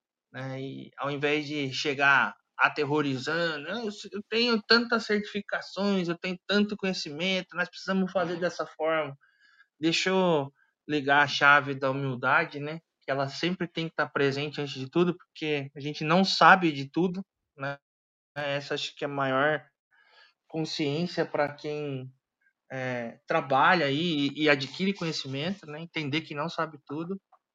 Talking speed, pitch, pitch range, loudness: 150 wpm, 155 Hz, 140-180 Hz, -27 LUFS